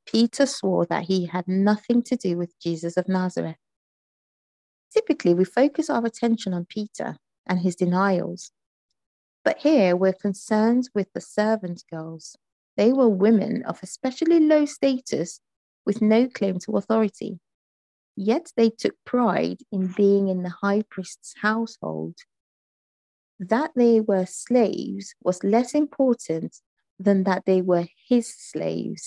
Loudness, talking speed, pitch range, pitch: -23 LUFS, 135 wpm, 180-235 Hz, 205 Hz